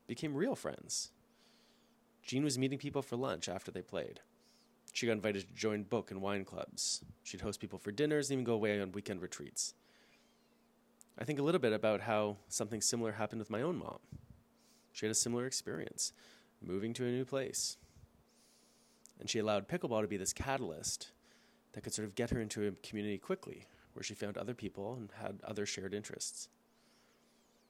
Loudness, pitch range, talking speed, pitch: -39 LUFS, 105-135 Hz, 185 wpm, 110 Hz